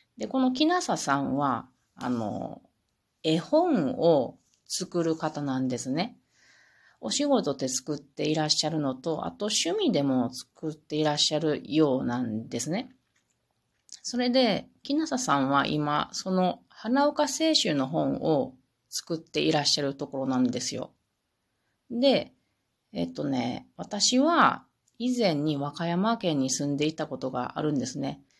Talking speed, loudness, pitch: 260 characters per minute, -27 LUFS, 155 Hz